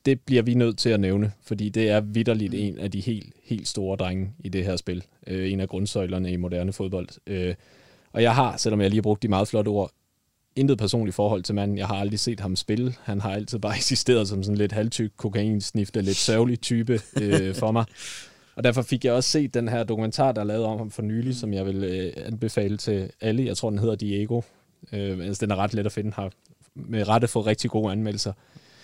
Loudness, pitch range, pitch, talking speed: -25 LUFS, 100-115 Hz, 105 Hz, 225 wpm